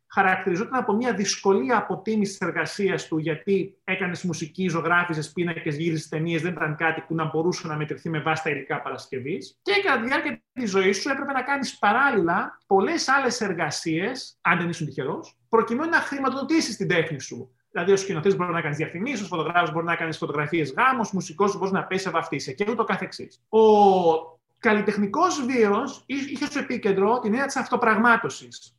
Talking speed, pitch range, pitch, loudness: 175 wpm, 165-230 Hz, 190 Hz, -24 LUFS